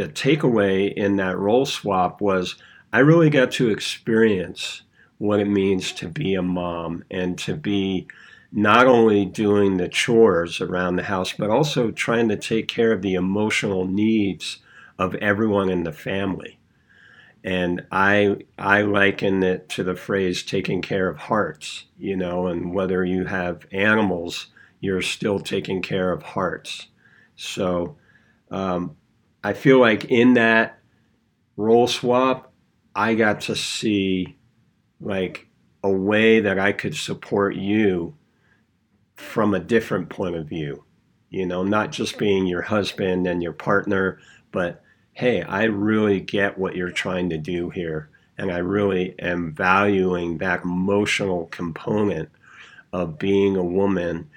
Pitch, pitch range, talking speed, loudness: 95 Hz, 90-105 Hz, 145 wpm, -21 LUFS